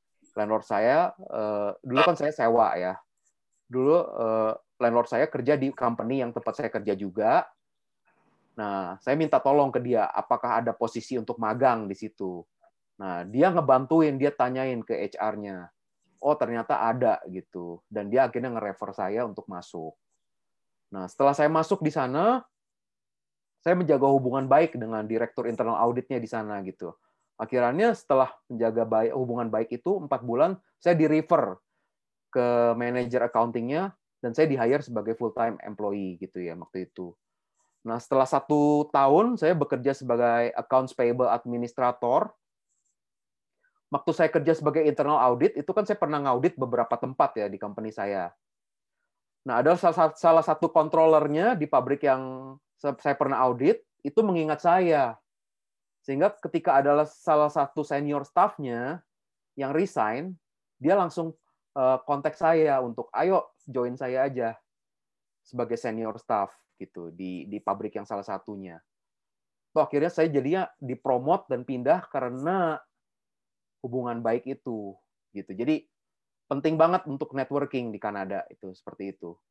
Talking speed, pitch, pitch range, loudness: 135 wpm, 130 Hz, 115-150 Hz, -26 LUFS